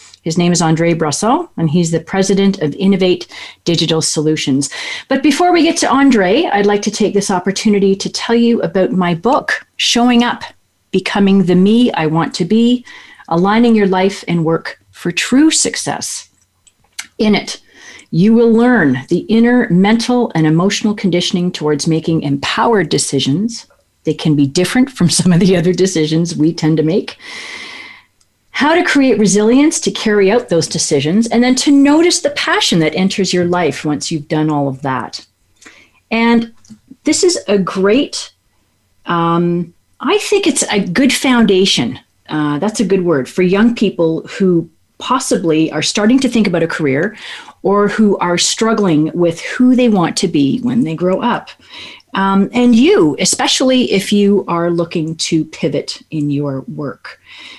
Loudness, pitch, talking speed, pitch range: -13 LUFS, 195 Hz, 165 wpm, 165-235 Hz